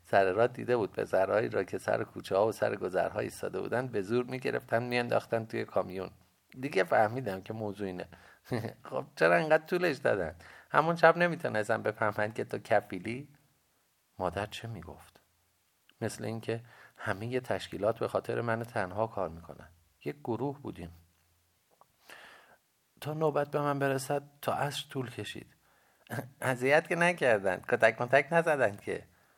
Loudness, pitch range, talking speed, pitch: -31 LUFS, 100-140 Hz, 145 wpm, 115 Hz